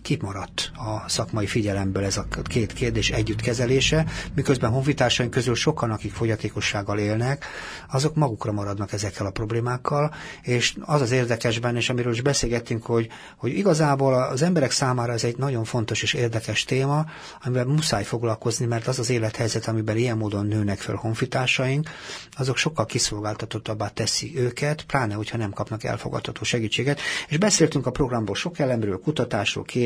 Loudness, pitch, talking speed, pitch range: -24 LUFS, 120 Hz, 150 wpm, 110-135 Hz